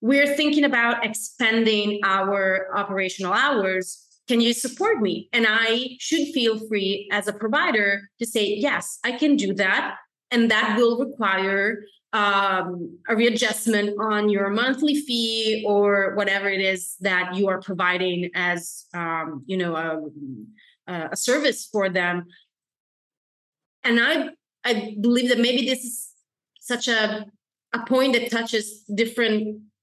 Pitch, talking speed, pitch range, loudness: 215 Hz, 140 wpm, 195-235 Hz, -22 LUFS